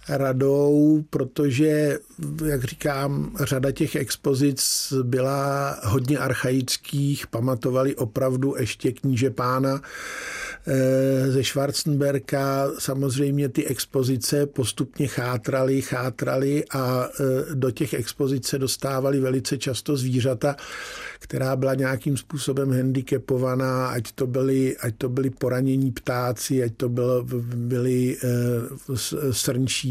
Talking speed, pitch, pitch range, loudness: 100 wpm, 135 Hz, 130-140 Hz, -24 LUFS